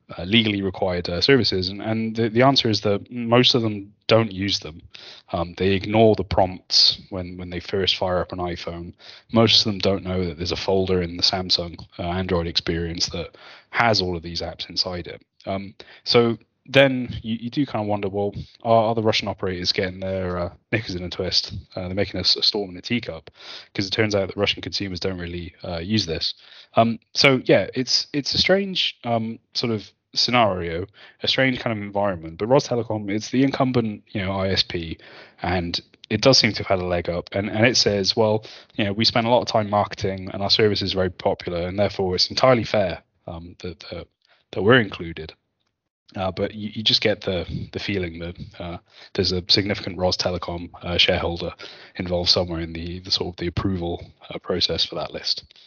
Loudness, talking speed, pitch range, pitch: -21 LUFS, 210 wpm, 90-110 Hz, 100 Hz